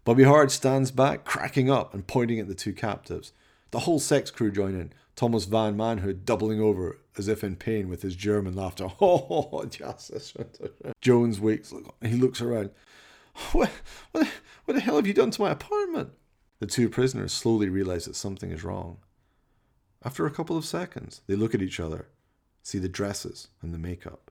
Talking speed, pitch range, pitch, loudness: 180 wpm, 95-125 Hz, 105 Hz, -27 LUFS